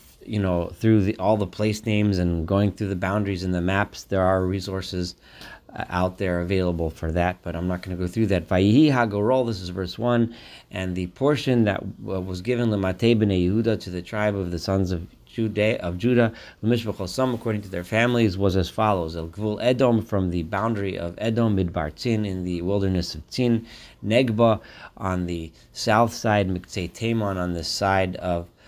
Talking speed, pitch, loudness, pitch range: 180 wpm, 100 Hz, -24 LUFS, 90-110 Hz